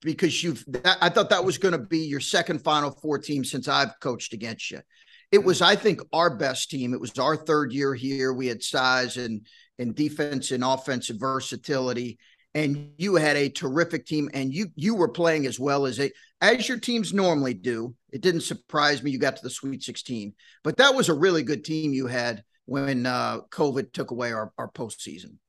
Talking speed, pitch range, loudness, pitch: 205 wpm, 130-165 Hz, -25 LUFS, 140 Hz